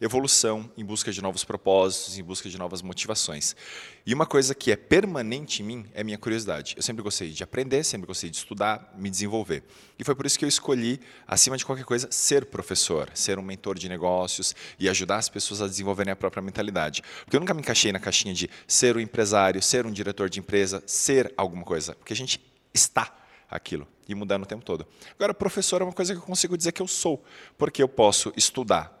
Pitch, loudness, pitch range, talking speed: 105 Hz, -25 LUFS, 95-130 Hz, 220 wpm